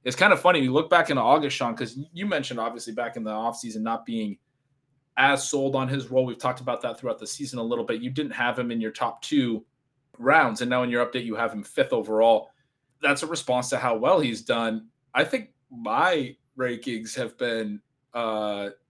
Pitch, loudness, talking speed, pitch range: 125 Hz, -25 LUFS, 220 wpm, 115-135 Hz